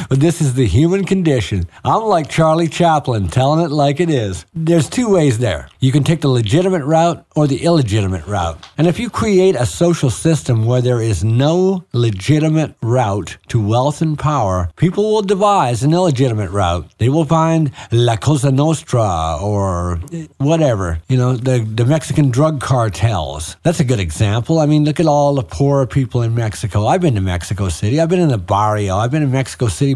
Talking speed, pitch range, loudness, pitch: 190 wpm, 110-160 Hz, -15 LUFS, 135 Hz